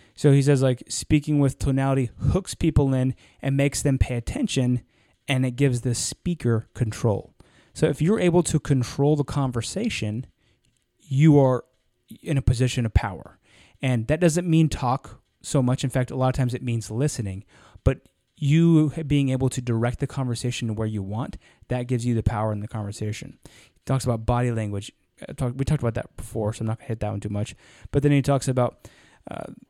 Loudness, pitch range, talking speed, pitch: -24 LUFS, 115-140 Hz, 200 wpm, 125 Hz